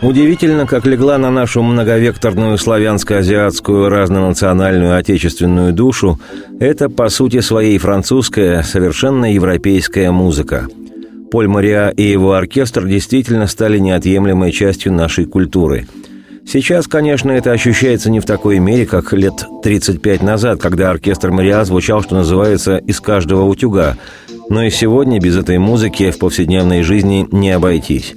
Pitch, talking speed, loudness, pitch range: 100 Hz, 130 wpm, -12 LUFS, 95-115 Hz